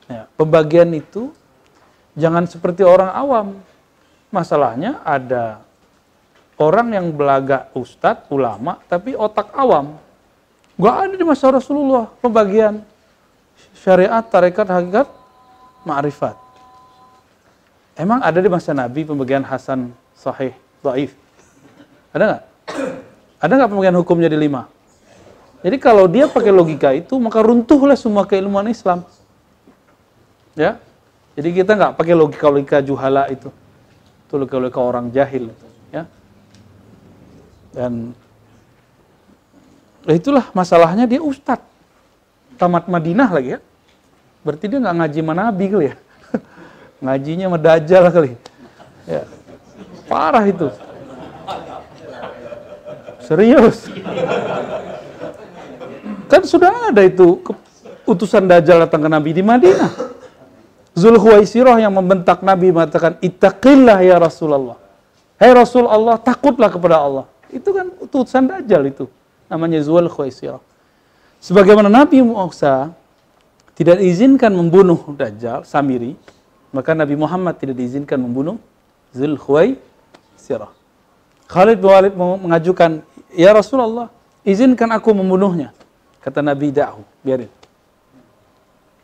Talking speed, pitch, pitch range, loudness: 105 wpm, 175 Hz, 140-220 Hz, -14 LUFS